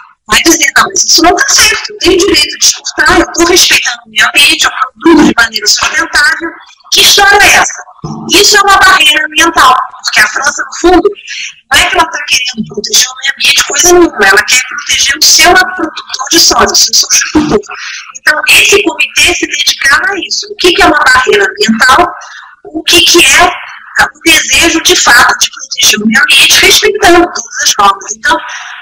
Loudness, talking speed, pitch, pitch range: -5 LUFS, 195 wpm, 335 Hz, 290-370 Hz